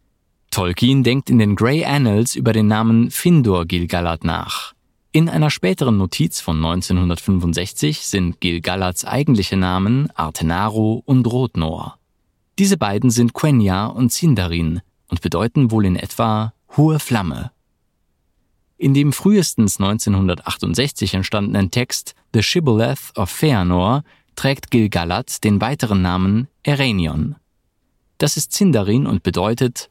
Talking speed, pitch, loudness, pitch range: 120 wpm, 110 Hz, -17 LUFS, 90-130 Hz